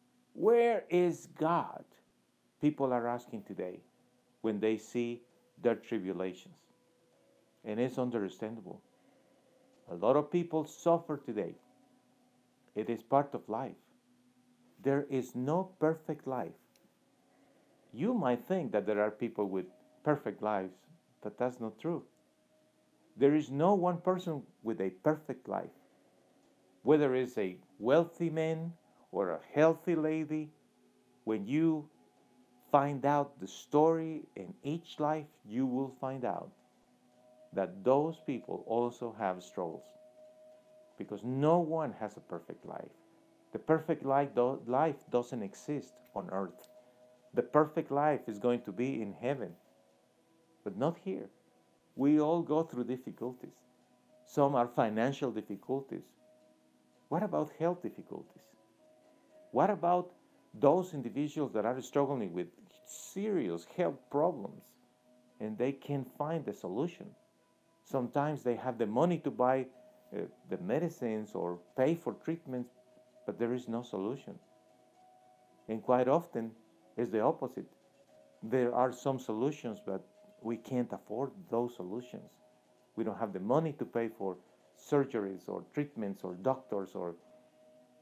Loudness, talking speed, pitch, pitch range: -34 LUFS, 130 wpm, 125 Hz, 110-155 Hz